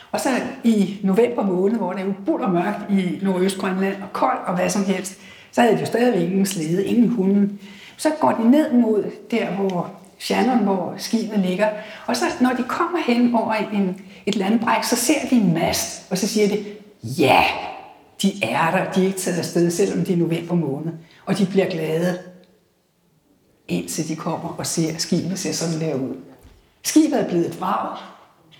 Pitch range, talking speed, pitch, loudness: 180-220 Hz, 195 wpm, 195 Hz, -21 LUFS